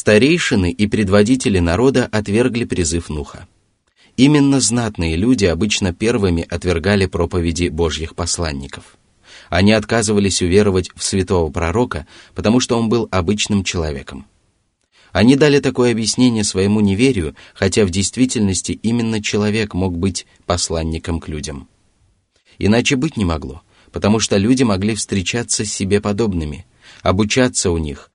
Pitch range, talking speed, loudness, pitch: 85-115 Hz, 125 wpm, -16 LUFS, 100 Hz